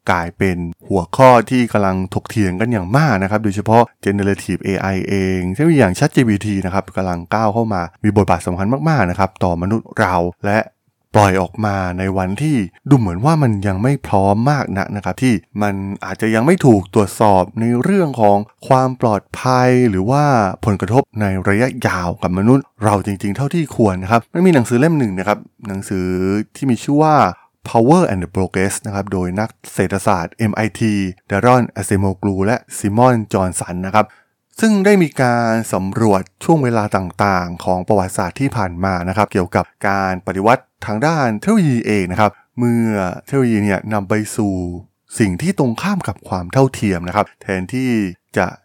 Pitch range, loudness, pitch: 95-125 Hz, -16 LUFS, 105 Hz